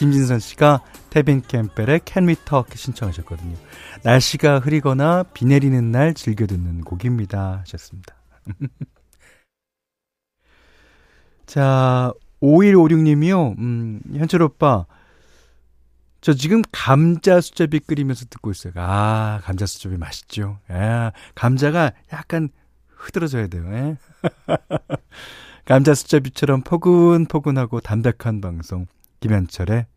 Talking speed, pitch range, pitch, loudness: 230 characters per minute, 100-150 Hz, 125 Hz, -18 LUFS